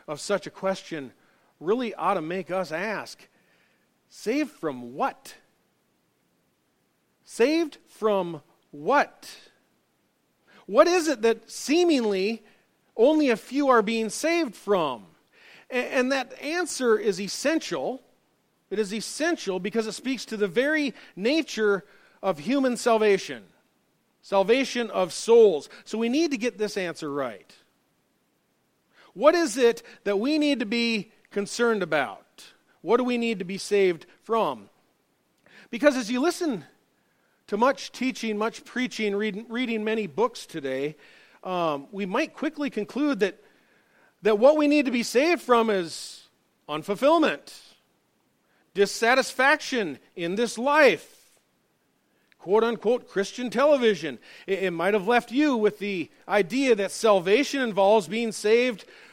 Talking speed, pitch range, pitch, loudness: 130 wpm, 200-270 Hz, 230 Hz, -25 LUFS